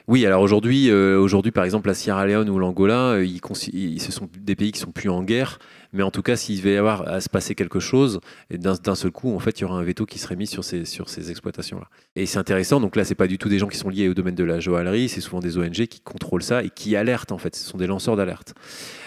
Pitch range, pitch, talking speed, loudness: 95-105 Hz, 95 Hz, 295 wpm, -22 LUFS